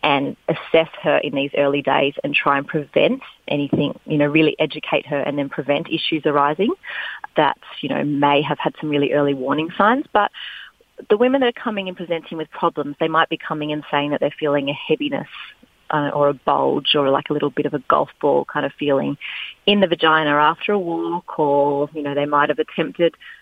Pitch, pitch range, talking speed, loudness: 150 Hz, 145-165 Hz, 215 wpm, -19 LUFS